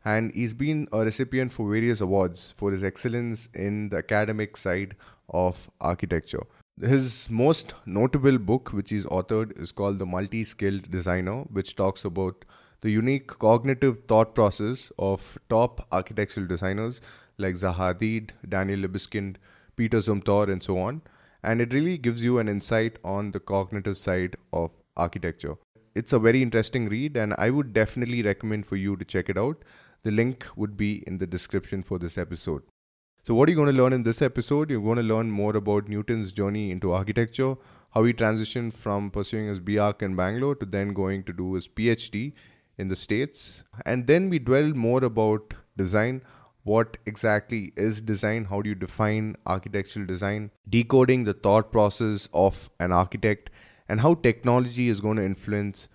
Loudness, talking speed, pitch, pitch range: -26 LUFS, 170 wpm, 105 Hz, 95-120 Hz